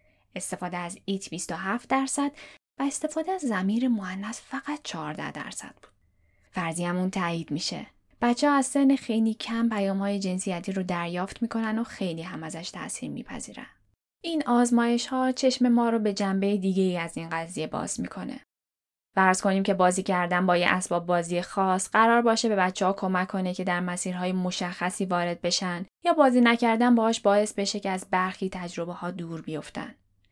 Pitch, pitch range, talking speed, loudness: 190 Hz, 180-230 Hz, 170 wpm, -26 LUFS